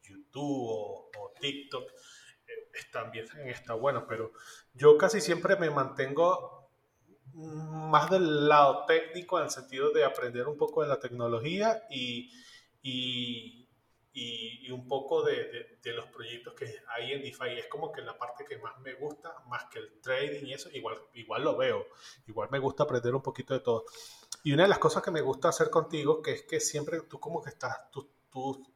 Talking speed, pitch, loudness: 190 wpm, 155 Hz, -31 LUFS